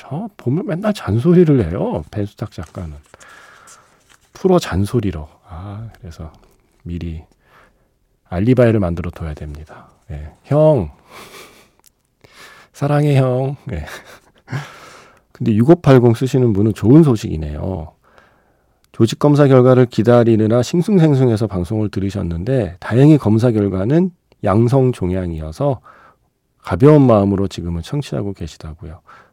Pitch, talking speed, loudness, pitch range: 110 Hz, 255 characters per minute, -15 LUFS, 90-135 Hz